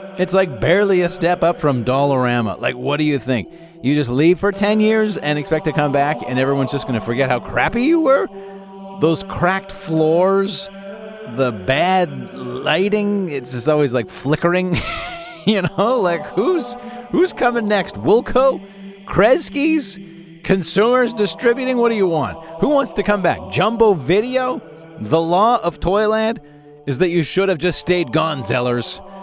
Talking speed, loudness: 160 wpm, -17 LUFS